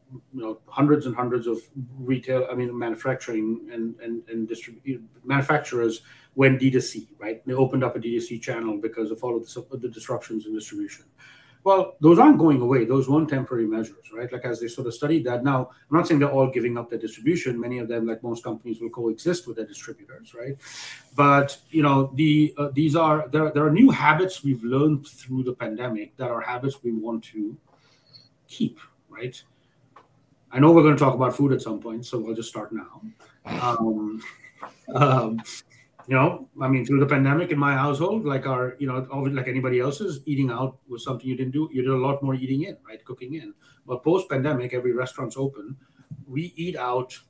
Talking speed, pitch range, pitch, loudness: 205 wpm, 120-140 Hz, 130 Hz, -23 LUFS